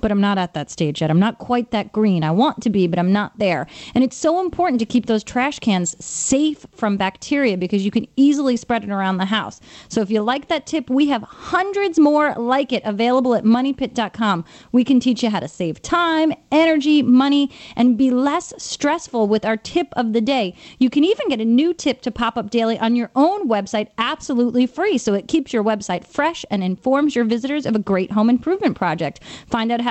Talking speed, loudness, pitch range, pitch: 225 wpm, -19 LUFS, 215-285 Hz, 240 Hz